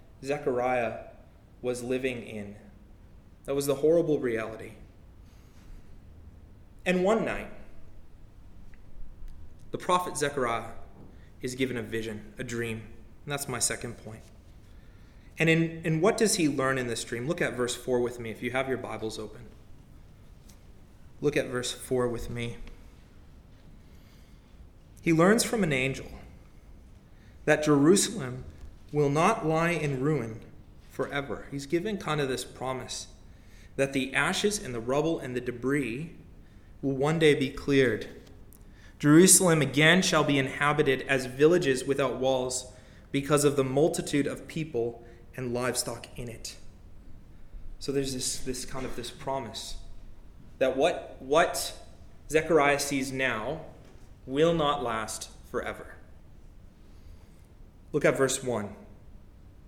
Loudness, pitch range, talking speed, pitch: -28 LUFS, 100-140 Hz, 130 wpm, 125 Hz